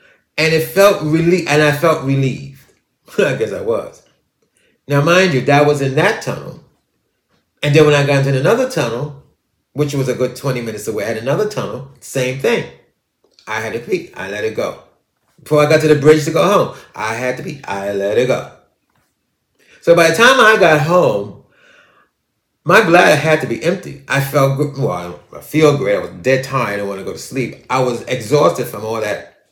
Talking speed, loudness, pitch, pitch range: 205 wpm, -15 LUFS, 145 Hz, 130-165 Hz